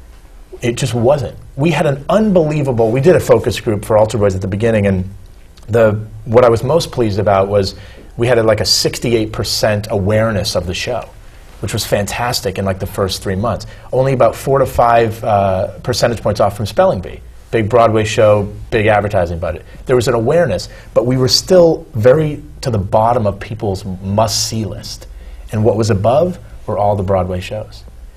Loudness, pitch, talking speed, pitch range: -14 LUFS, 110 Hz, 190 wpm, 100-120 Hz